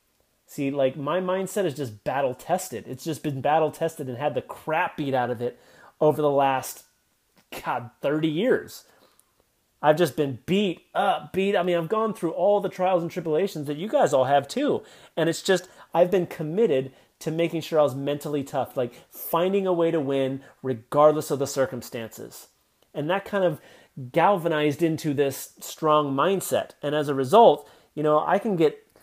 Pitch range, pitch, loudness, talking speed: 140-175 Hz, 155 Hz, -24 LUFS, 185 wpm